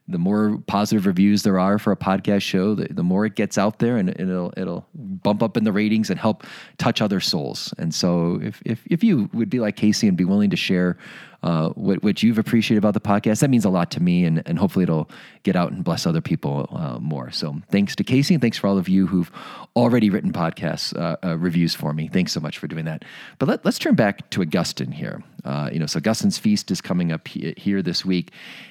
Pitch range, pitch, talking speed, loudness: 90-110 Hz, 100 Hz, 240 wpm, -21 LUFS